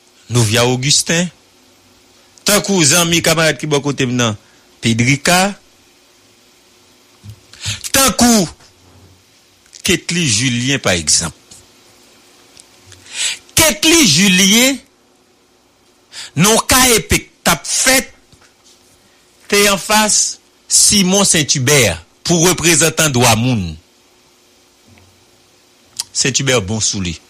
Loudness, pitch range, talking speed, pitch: -12 LUFS, 110-185 Hz, 75 wpm, 140 Hz